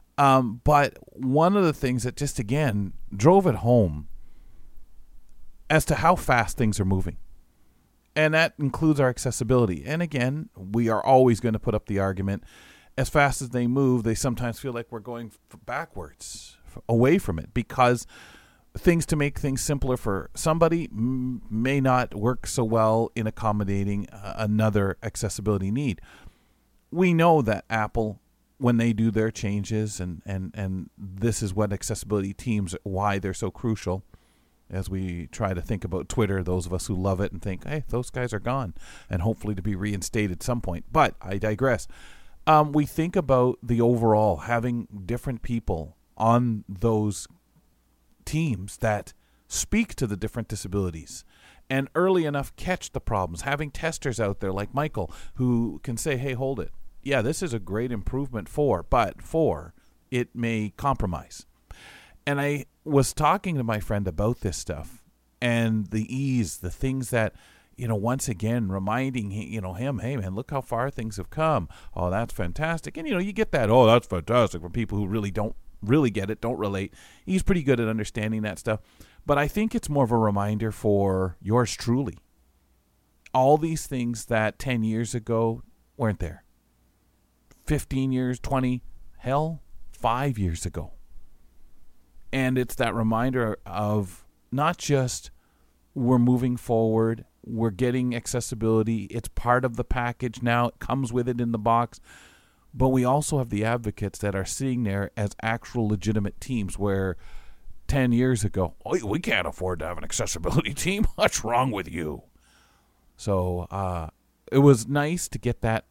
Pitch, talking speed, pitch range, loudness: 115 Hz, 165 wpm, 100-130 Hz, -26 LUFS